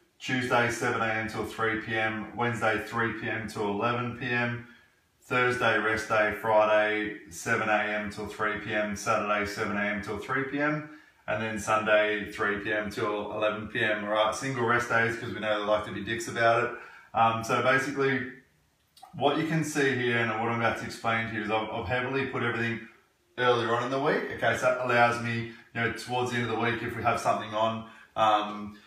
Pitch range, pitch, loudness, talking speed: 105-120 Hz, 115 Hz, -28 LUFS, 195 wpm